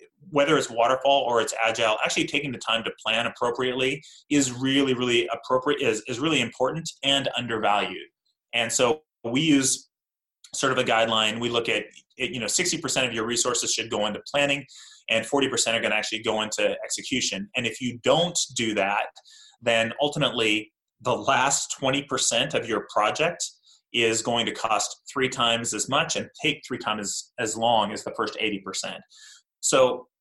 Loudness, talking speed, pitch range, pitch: -24 LUFS, 175 wpm, 115-140 Hz, 125 Hz